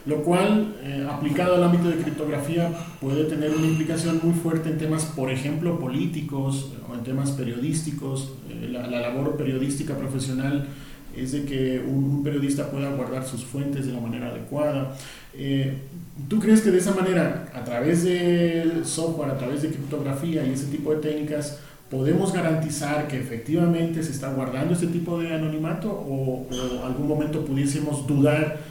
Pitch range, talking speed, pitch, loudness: 135-160 Hz, 165 wpm, 145 Hz, -25 LUFS